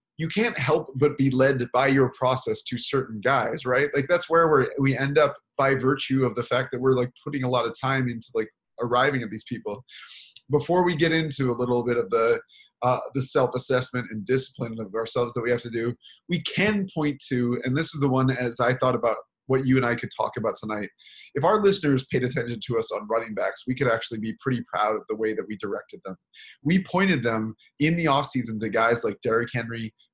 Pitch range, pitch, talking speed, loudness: 120-140 Hz, 130 Hz, 230 wpm, -25 LUFS